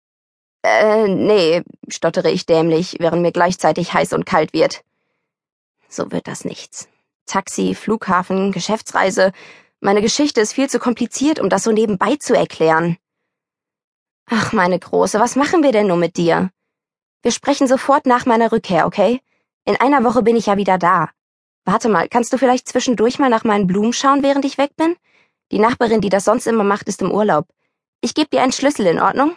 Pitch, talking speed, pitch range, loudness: 220 Hz, 180 wpm, 190-255 Hz, -16 LUFS